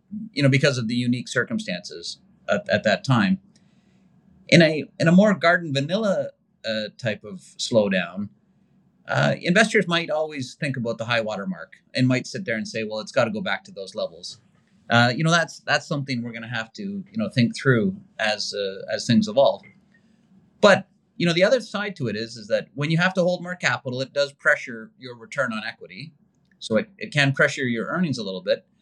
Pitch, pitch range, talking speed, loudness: 160 Hz, 120-195 Hz, 210 wpm, -23 LUFS